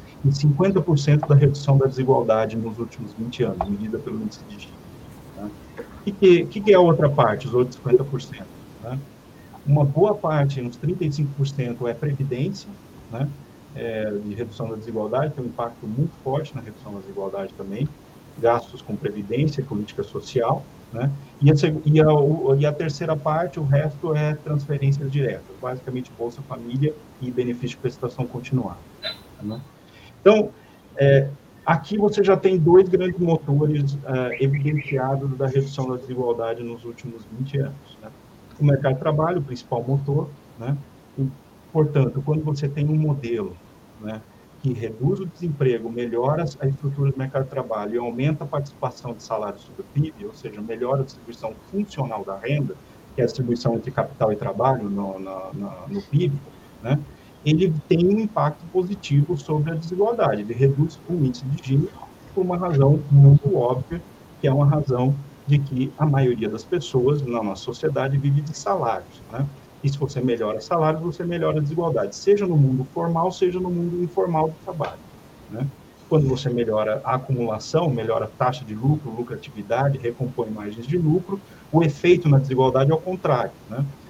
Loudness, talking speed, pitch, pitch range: -22 LUFS, 165 wpm, 140 Hz, 125-155 Hz